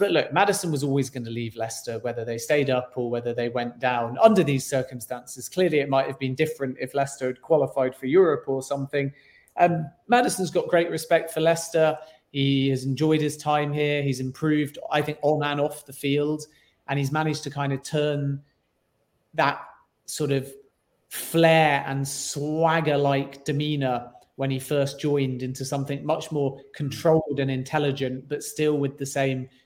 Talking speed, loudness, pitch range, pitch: 180 wpm, -25 LUFS, 135-150 Hz, 140 Hz